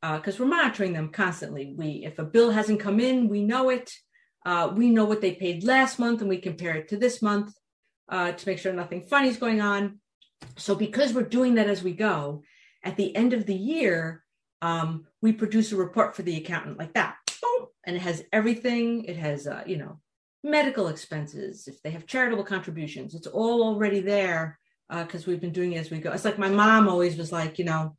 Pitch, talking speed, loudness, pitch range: 195 Hz, 220 wpm, -26 LUFS, 170-225 Hz